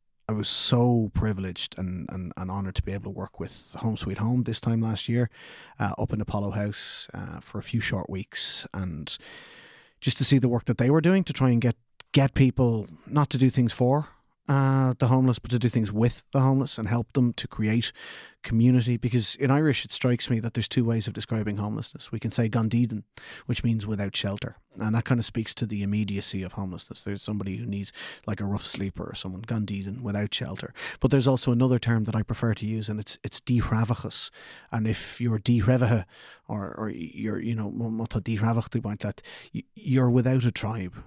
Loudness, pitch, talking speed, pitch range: -26 LUFS, 115 Hz, 205 wpm, 105-125 Hz